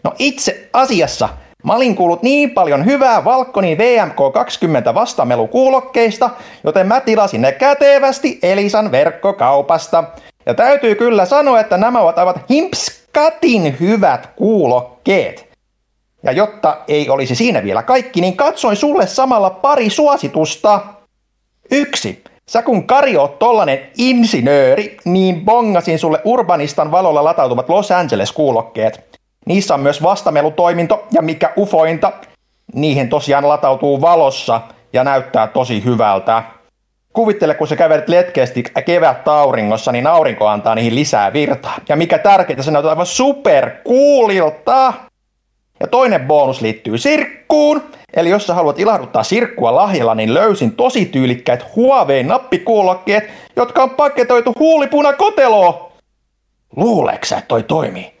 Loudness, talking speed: -13 LUFS, 120 wpm